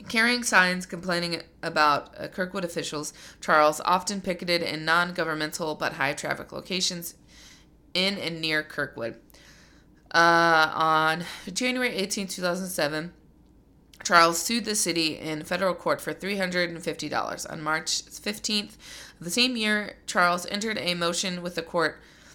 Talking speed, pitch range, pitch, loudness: 125 wpm, 160-185 Hz, 175 Hz, -25 LUFS